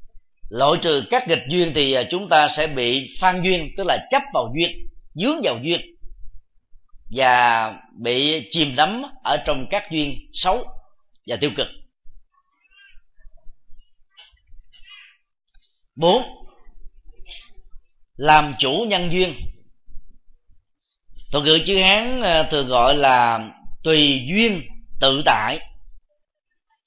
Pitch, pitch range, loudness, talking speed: 155 Hz, 135-195 Hz, -19 LUFS, 105 wpm